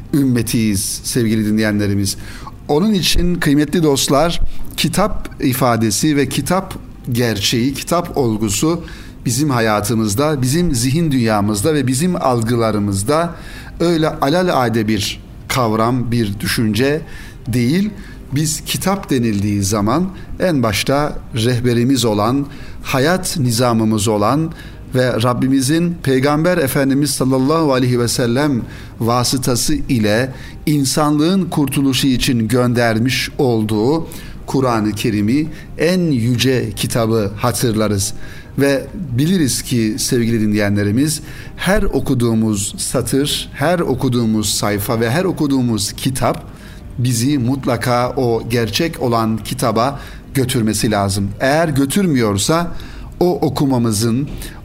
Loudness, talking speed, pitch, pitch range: -16 LUFS, 100 wpm, 125 Hz, 110-145 Hz